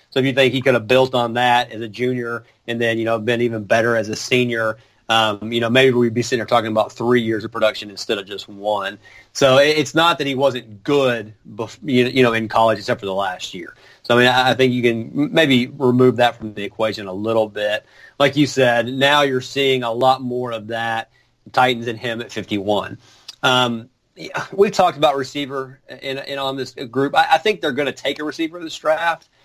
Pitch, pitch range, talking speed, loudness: 125 Hz, 115-135 Hz, 230 wpm, -18 LUFS